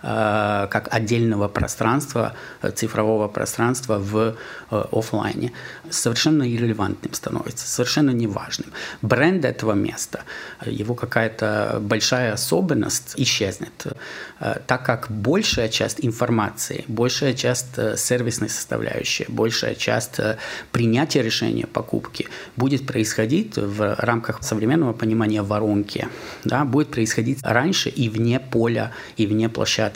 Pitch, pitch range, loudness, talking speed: 115 Hz, 110-125 Hz, -22 LUFS, 100 wpm